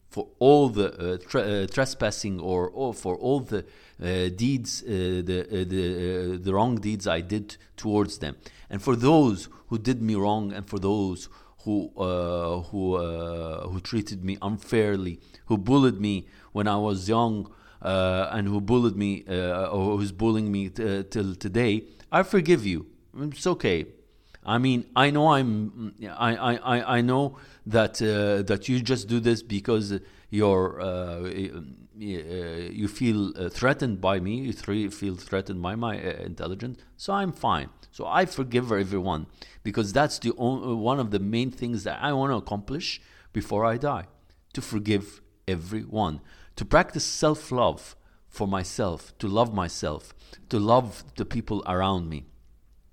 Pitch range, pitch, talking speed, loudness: 95-120 Hz, 105 Hz, 160 wpm, -26 LUFS